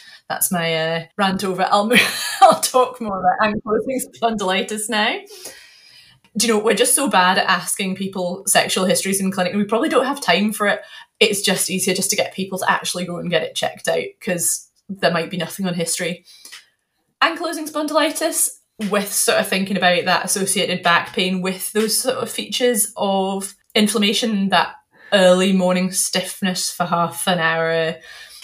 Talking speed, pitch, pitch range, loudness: 180 wpm, 195 Hz, 180-225 Hz, -18 LUFS